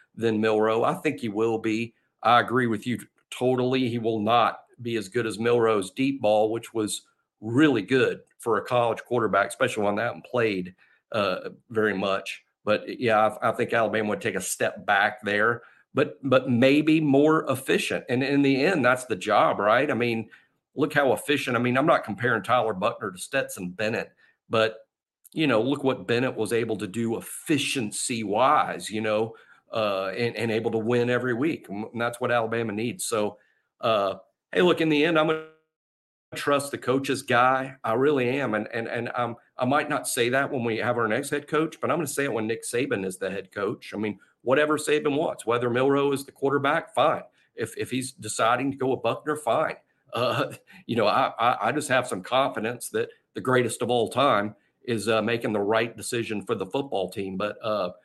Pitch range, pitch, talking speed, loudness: 110-135 Hz, 120 Hz, 205 wpm, -25 LUFS